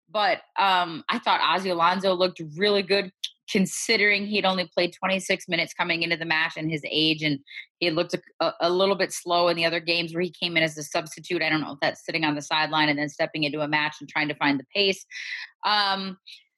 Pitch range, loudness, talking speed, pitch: 155-190 Hz, -24 LUFS, 230 wpm, 170 Hz